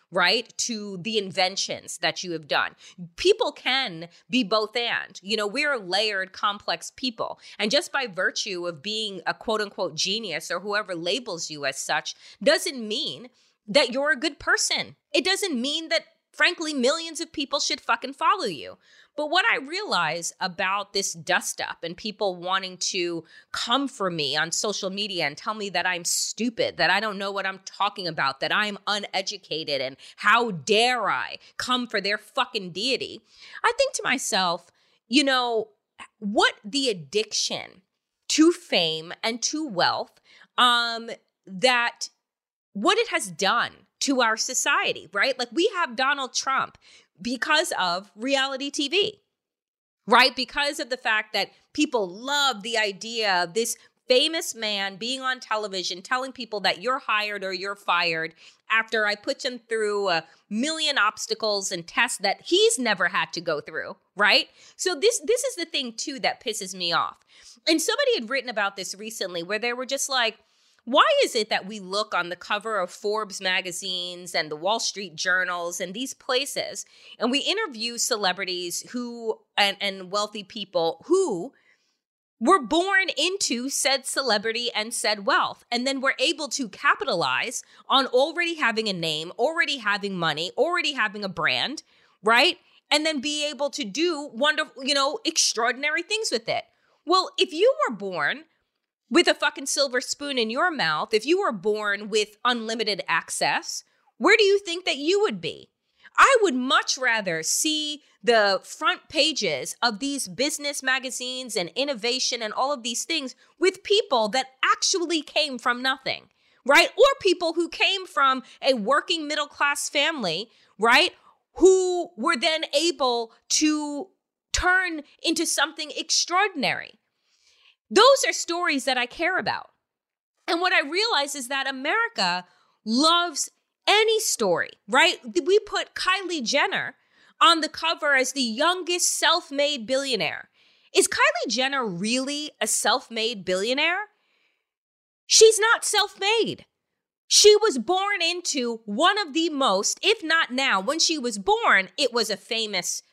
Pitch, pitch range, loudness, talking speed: 255 Hz, 205-320 Hz, -23 LUFS, 160 wpm